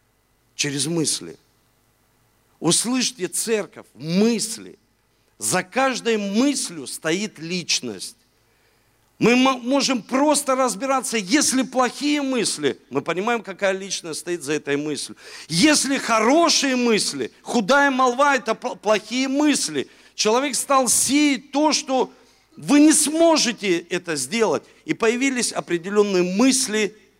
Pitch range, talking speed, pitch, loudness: 170-265 Hz, 105 wpm, 225 Hz, -20 LUFS